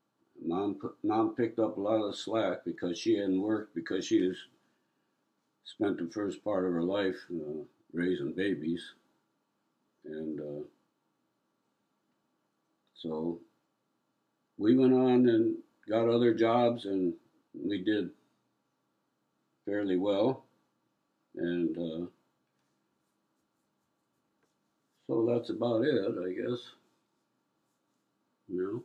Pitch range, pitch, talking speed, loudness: 85-115 Hz, 100 Hz, 105 wpm, -31 LUFS